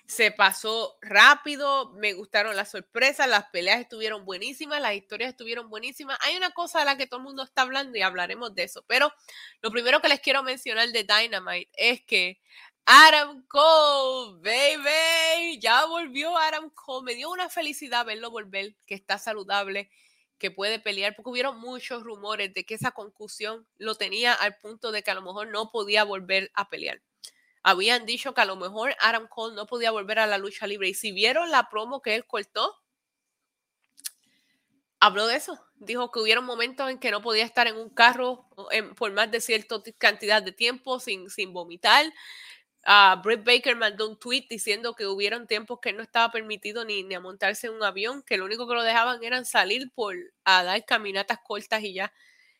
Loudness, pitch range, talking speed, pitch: -24 LUFS, 210-260 Hz, 190 wpm, 230 Hz